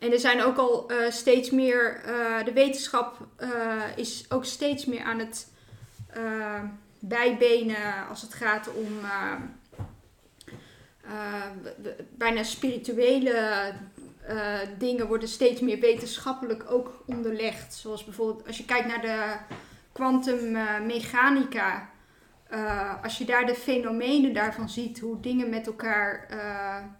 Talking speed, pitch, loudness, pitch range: 130 wpm, 230 Hz, -27 LUFS, 215-245 Hz